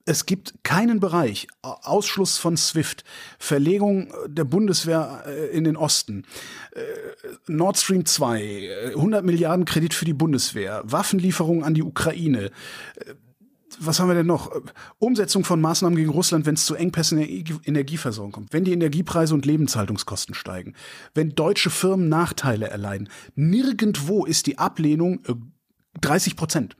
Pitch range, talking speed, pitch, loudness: 145-185 Hz, 135 wpm, 165 Hz, -22 LUFS